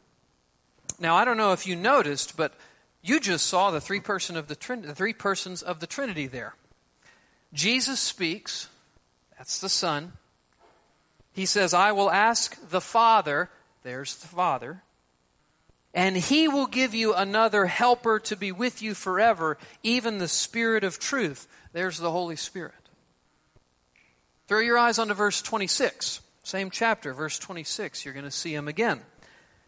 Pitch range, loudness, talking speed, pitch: 155-225 Hz, -26 LUFS, 155 wpm, 190 Hz